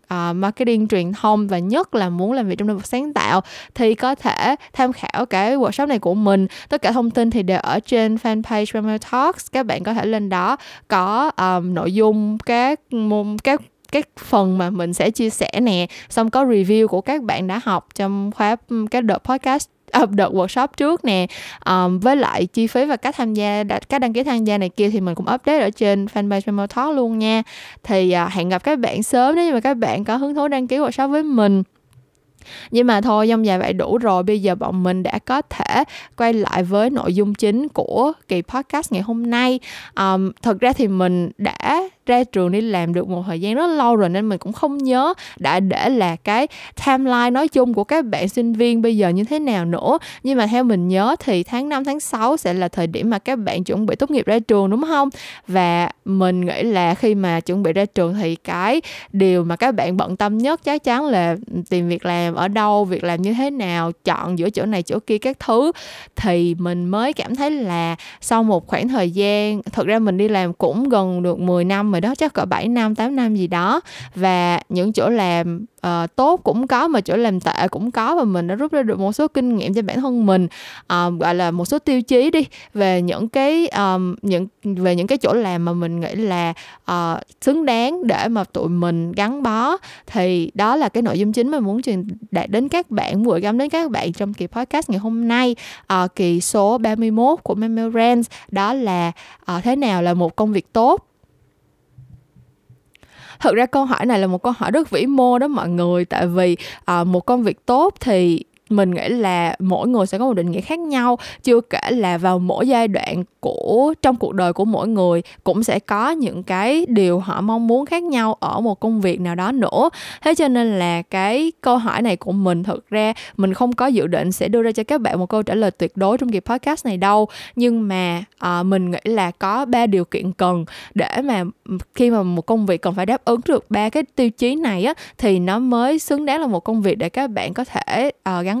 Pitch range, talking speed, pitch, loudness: 185-250 Hz, 230 wpm, 215 Hz, -18 LUFS